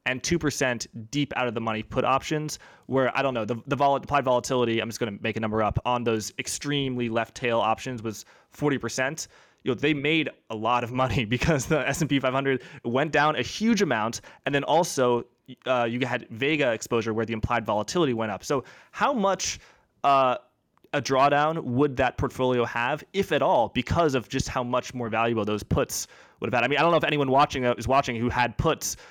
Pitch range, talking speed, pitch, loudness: 120-145 Hz, 220 wpm, 130 Hz, -25 LUFS